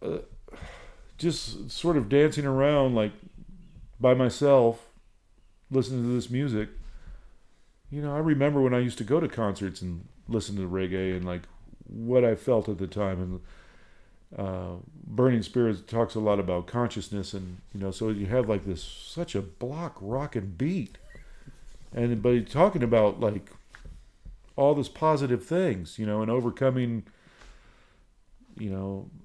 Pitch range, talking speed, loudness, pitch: 95-135 Hz, 155 wpm, -27 LUFS, 115 Hz